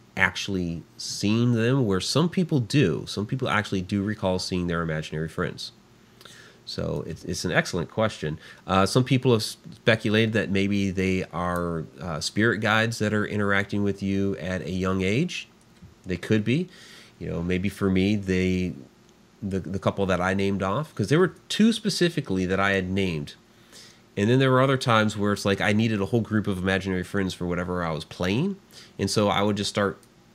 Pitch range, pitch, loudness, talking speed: 95-115 Hz, 100 Hz, -25 LUFS, 190 wpm